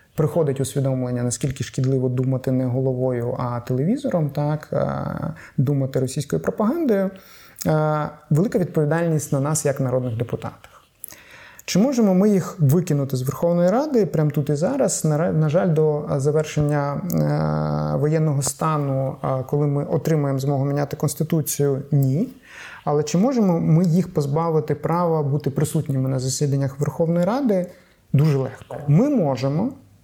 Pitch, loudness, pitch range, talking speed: 150 Hz, -21 LUFS, 135-165 Hz, 125 wpm